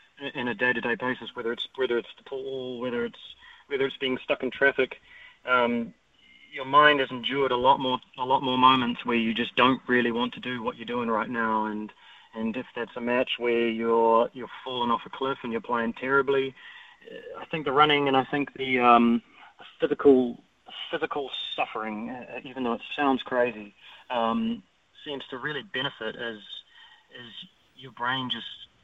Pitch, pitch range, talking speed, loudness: 125 Hz, 120-135 Hz, 190 wpm, -26 LUFS